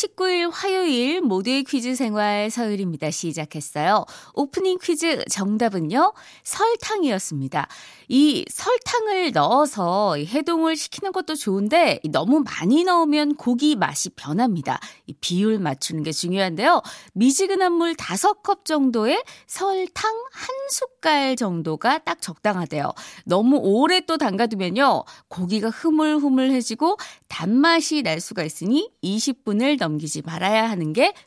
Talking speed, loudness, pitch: 280 characters per minute, -21 LUFS, 270 Hz